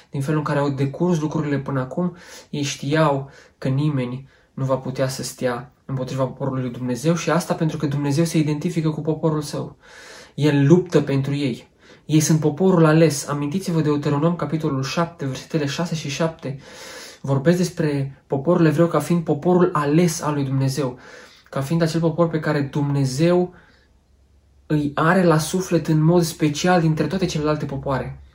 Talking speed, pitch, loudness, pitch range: 165 wpm, 150 Hz, -21 LUFS, 135-165 Hz